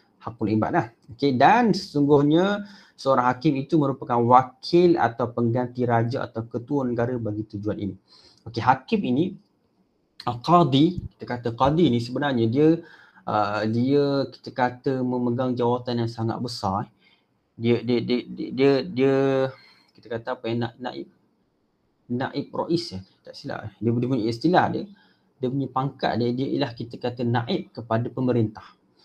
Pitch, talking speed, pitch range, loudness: 125 Hz, 150 wpm, 115-140 Hz, -24 LUFS